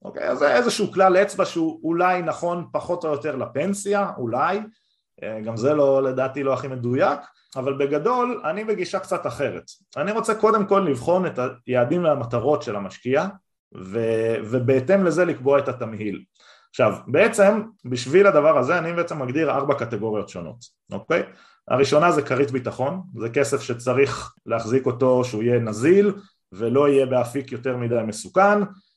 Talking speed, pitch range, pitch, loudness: 155 wpm, 125-190 Hz, 140 Hz, -21 LUFS